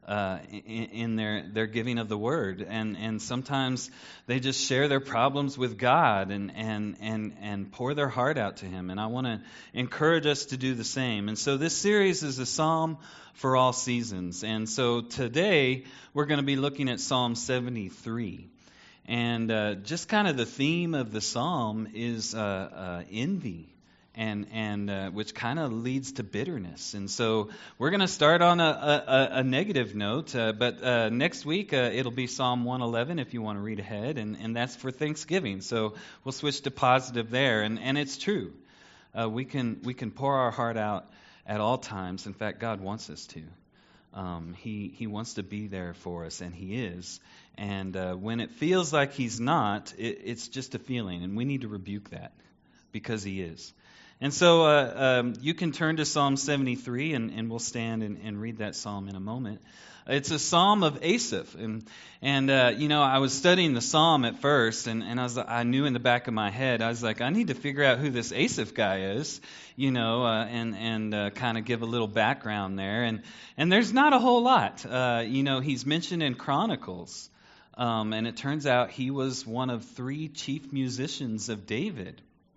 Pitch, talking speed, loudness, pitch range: 120 Hz, 205 wpm, -28 LUFS, 110-140 Hz